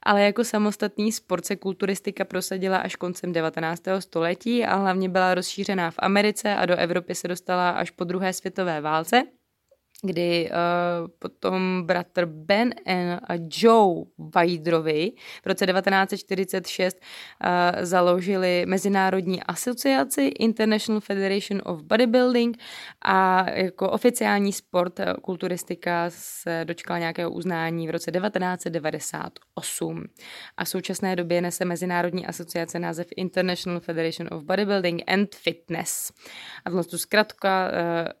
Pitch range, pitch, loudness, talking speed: 175-195 Hz, 185 Hz, -24 LUFS, 120 wpm